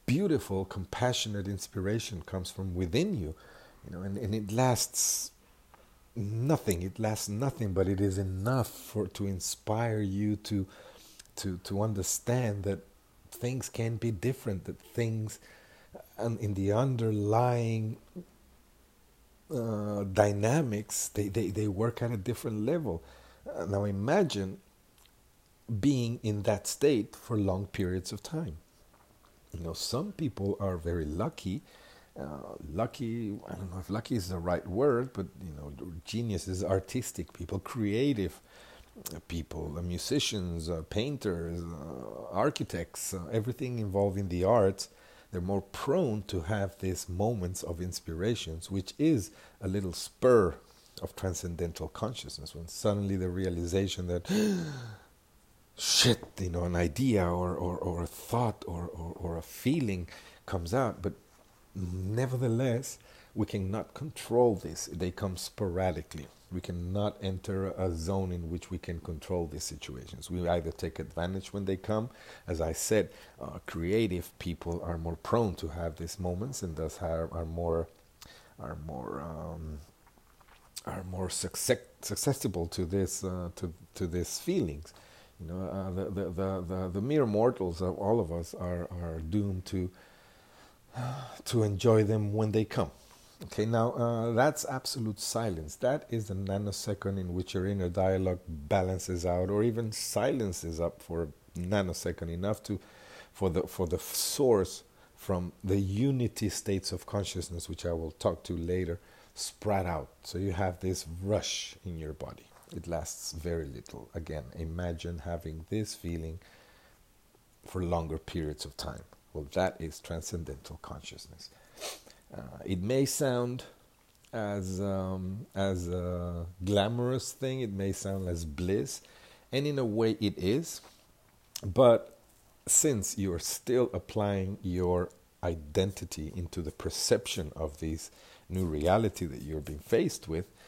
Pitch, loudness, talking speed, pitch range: 95 Hz, -33 LUFS, 145 wpm, 85-110 Hz